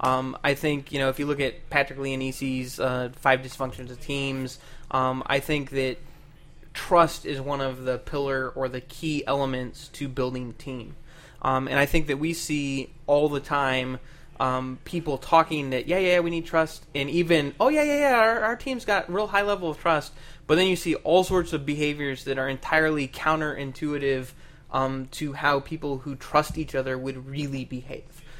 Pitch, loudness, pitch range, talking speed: 140 Hz, -26 LUFS, 130-155 Hz, 195 wpm